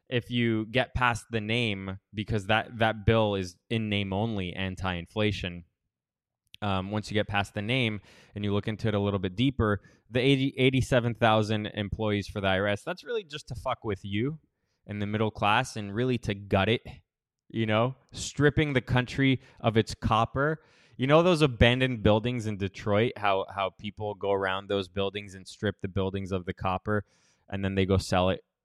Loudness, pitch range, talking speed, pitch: -28 LUFS, 100-120 Hz, 185 wpm, 110 Hz